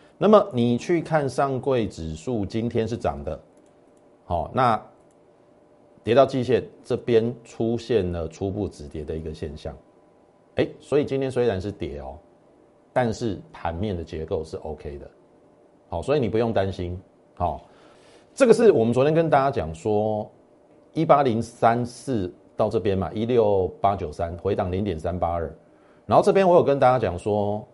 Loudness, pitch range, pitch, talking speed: -23 LUFS, 90-125 Hz, 110 Hz, 235 characters per minute